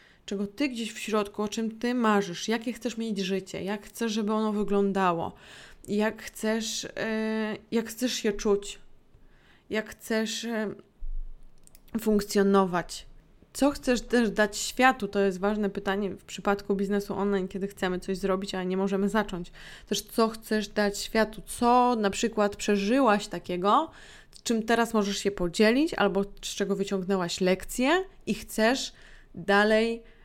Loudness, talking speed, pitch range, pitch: -28 LUFS, 145 wpm, 195-225 Hz, 210 Hz